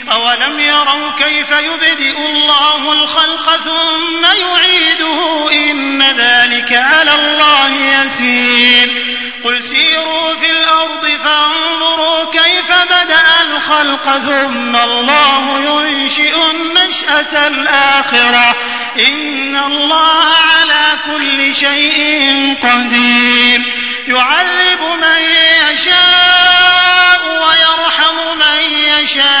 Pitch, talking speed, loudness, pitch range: 300 Hz, 80 wpm, -8 LUFS, 275-320 Hz